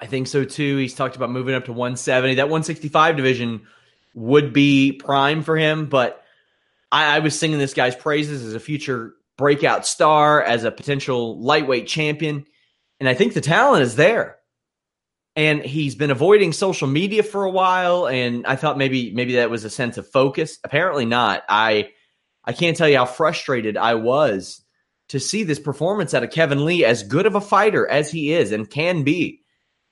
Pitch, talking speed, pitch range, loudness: 145 Hz, 190 wpm, 130-155 Hz, -19 LUFS